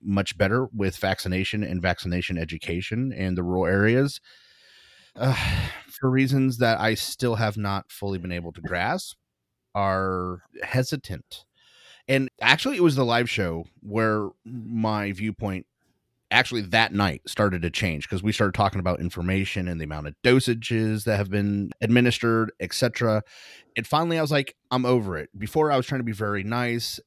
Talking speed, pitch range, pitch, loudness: 165 wpm, 95-125 Hz, 110 Hz, -25 LUFS